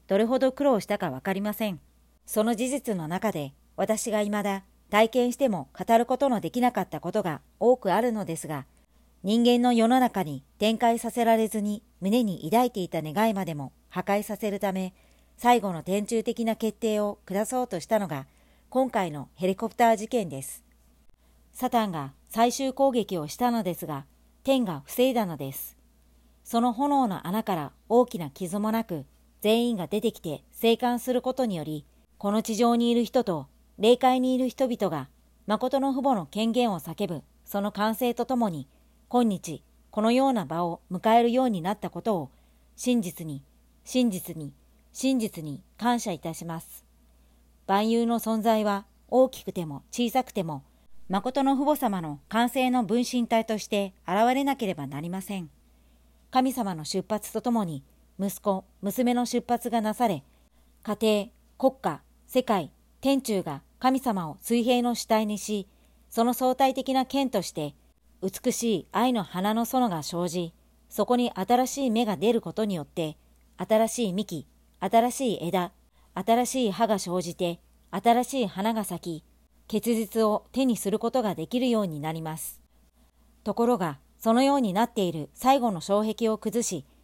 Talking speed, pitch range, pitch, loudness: 295 characters per minute, 175-240 Hz, 215 Hz, -27 LUFS